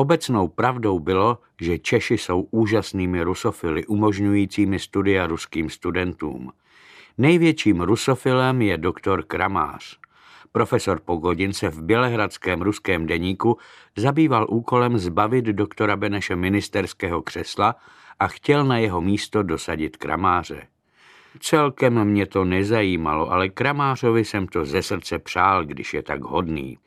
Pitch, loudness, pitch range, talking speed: 105 Hz, -22 LUFS, 90-120 Hz, 120 wpm